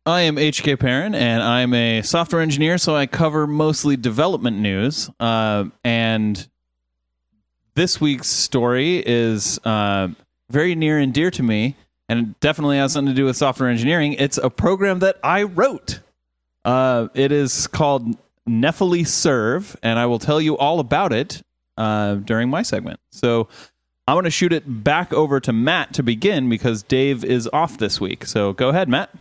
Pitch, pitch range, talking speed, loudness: 130 Hz, 115-150 Hz, 170 wpm, -19 LUFS